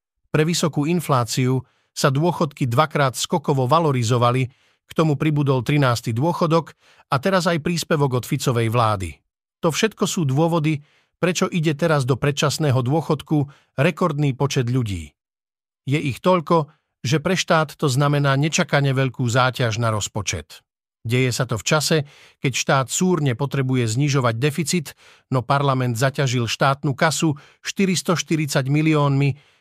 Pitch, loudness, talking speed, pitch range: 145 Hz, -20 LUFS, 130 wpm, 130-160 Hz